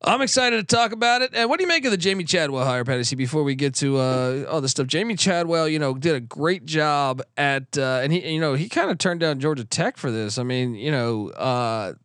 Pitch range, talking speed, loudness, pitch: 130-180 Hz, 265 wpm, -22 LUFS, 150 Hz